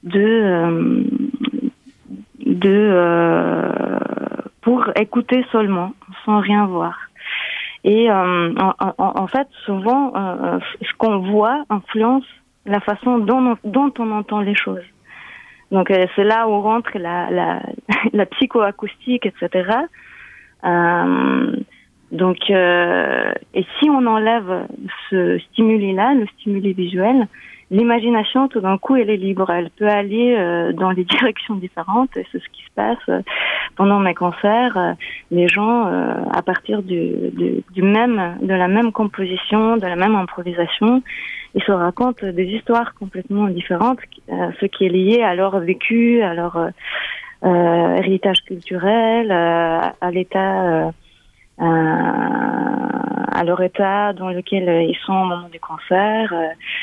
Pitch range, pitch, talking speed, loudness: 185-235 Hz, 205 Hz, 140 wpm, -18 LUFS